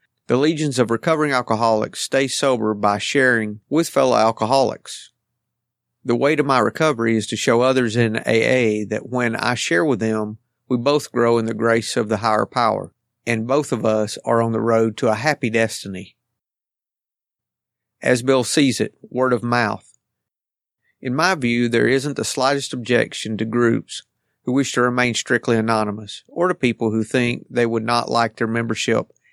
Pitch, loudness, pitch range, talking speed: 120 Hz, -19 LUFS, 115-130 Hz, 175 wpm